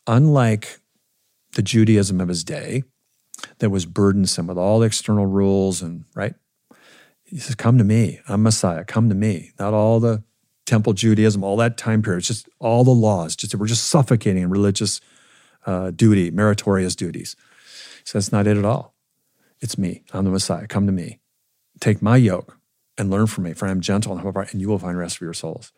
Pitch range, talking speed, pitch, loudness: 95-115 Hz, 200 wpm, 105 Hz, -20 LUFS